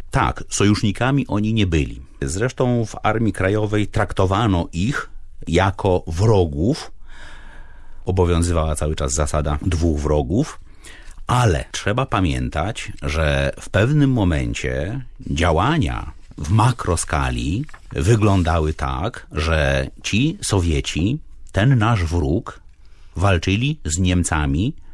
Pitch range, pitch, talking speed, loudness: 75-105 Hz, 90 Hz, 95 wpm, -20 LUFS